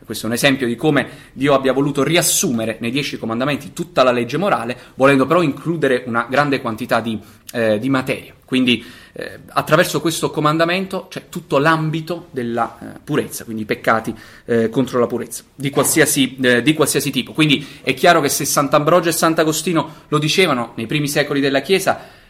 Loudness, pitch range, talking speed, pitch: -17 LUFS, 120-155 Hz, 180 wpm, 140 Hz